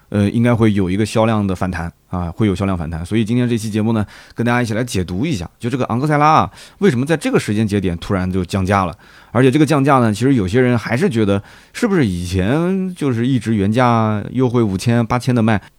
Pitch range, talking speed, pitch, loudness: 100-125 Hz, 370 characters per minute, 110 Hz, -17 LUFS